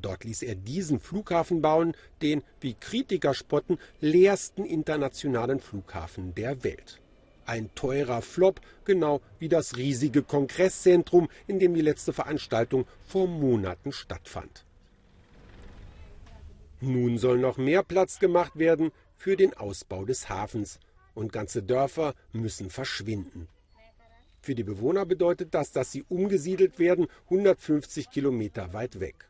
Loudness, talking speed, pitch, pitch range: -27 LUFS, 125 wpm, 135 Hz, 105-165 Hz